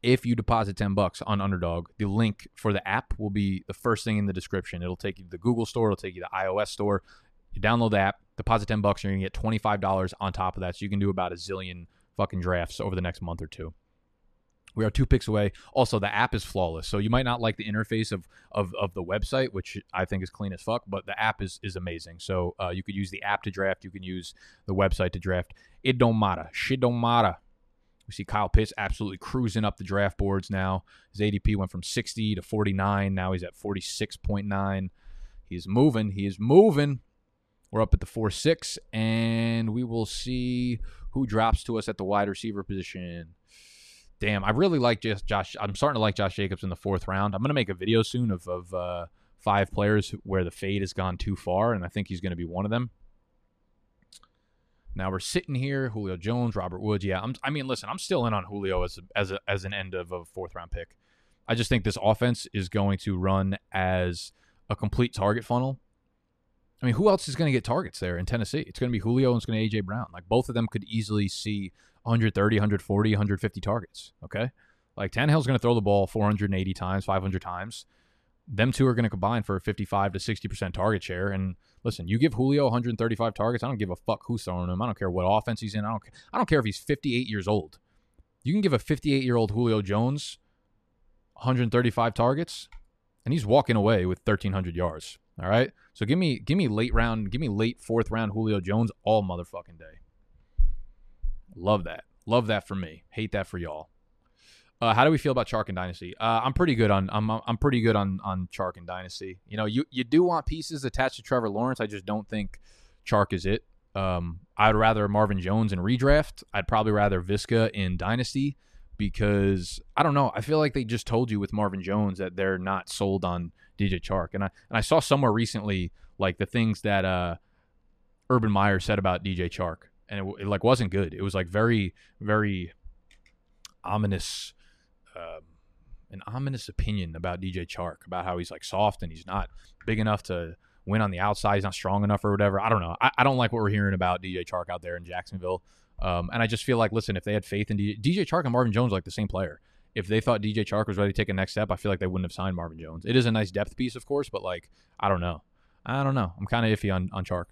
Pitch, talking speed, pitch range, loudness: 105 Hz, 235 wpm, 95-115 Hz, -27 LUFS